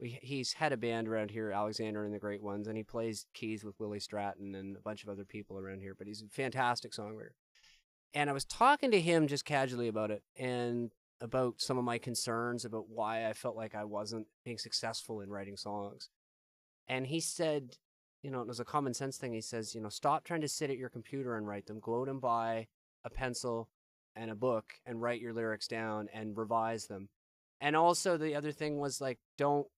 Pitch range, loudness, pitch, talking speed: 105-130 Hz, -37 LUFS, 115 Hz, 220 wpm